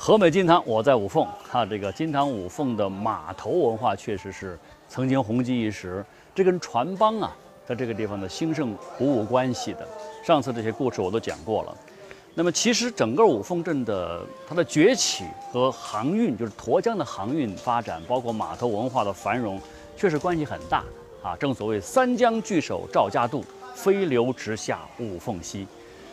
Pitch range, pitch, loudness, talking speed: 110-170 Hz, 125 Hz, -25 LUFS, 270 characters per minute